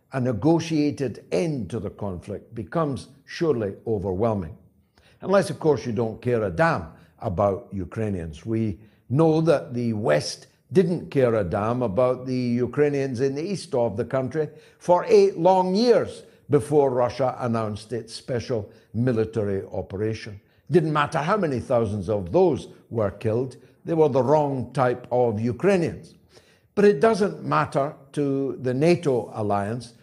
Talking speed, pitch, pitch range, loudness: 145 wpm, 125 Hz, 110-155 Hz, -24 LUFS